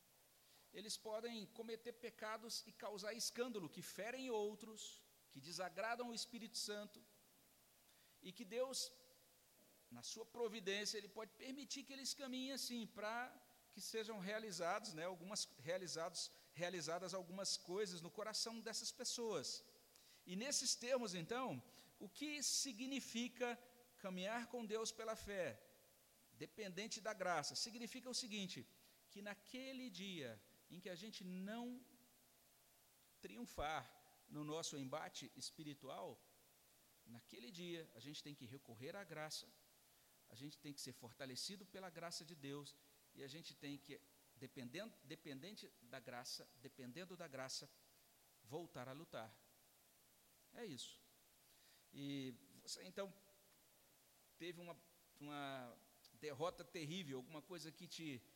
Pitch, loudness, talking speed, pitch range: 190 Hz, -49 LUFS, 125 wpm, 150-225 Hz